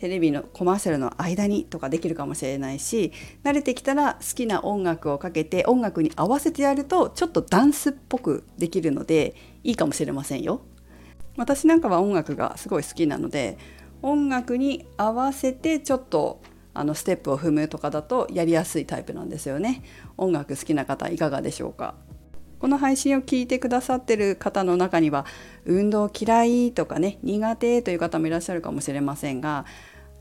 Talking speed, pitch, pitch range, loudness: 395 characters per minute, 185 Hz, 155-255 Hz, -24 LUFS